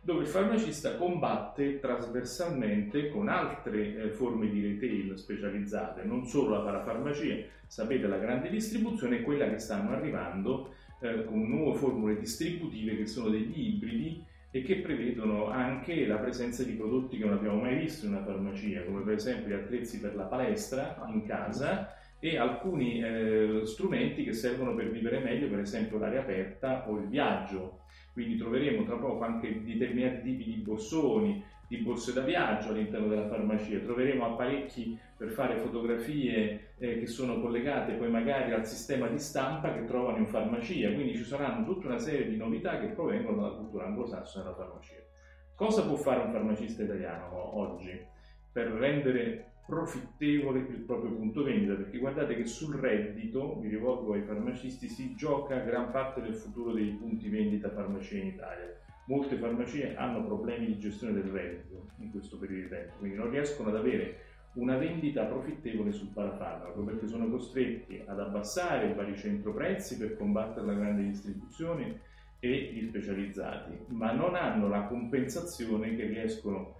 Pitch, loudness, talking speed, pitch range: 115 Hz, -34 LUFS, 165 wpm, 105-135 Hz